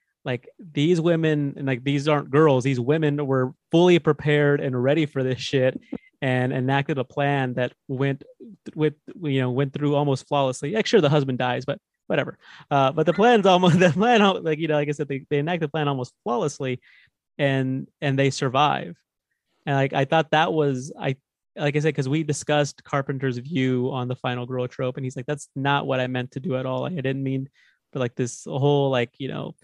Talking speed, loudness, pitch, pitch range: 215 wpm, -23 LUFS, 140 Hz, 130-150 Hz